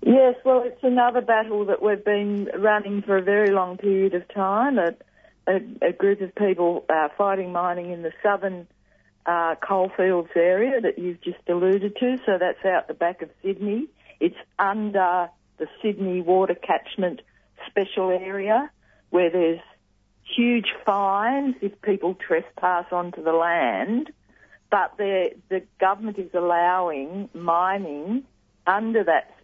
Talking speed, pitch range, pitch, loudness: 140 wpm, 180-210 Hz, 195 Hz, -23 LUFS